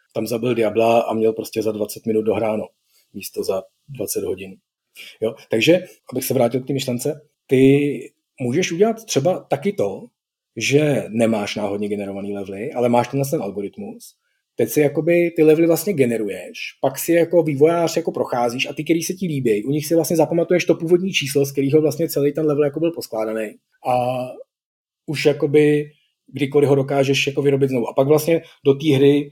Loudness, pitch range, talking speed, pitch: -19 LUFS, 120-165 Hz, 180 wpm, 145 Hz